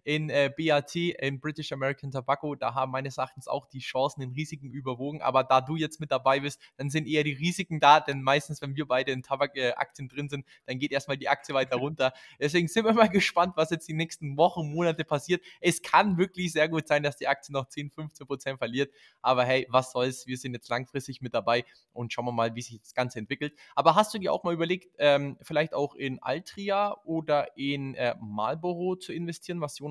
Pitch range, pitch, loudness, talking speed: 130-160 Hz, 145 Hz, -28 LUFS, 225 wpm